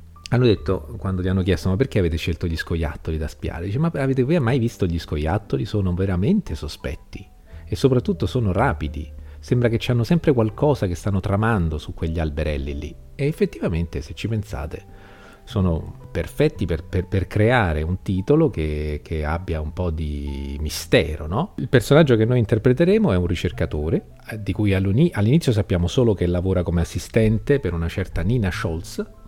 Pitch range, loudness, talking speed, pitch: 80-115 Hz, -22 LUFS, 175 wpm, 95 Hz